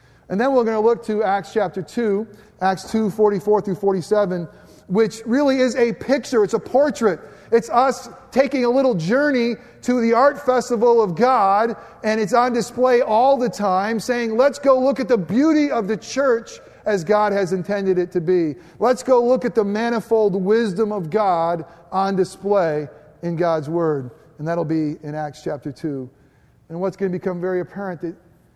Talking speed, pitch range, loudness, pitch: 185 wpm, 180-245 Hz, -19 LUFS, 210 Hz